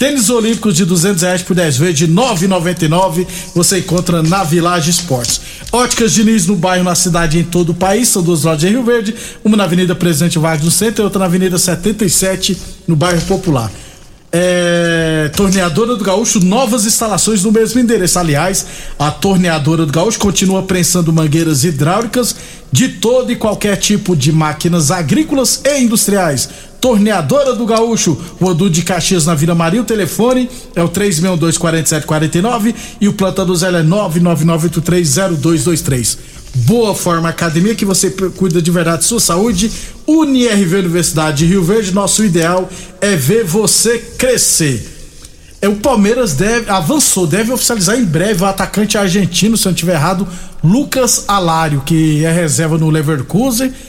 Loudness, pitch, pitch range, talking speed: -12 LUFS, 185 Hz, 170-215 Hz, 160 wpm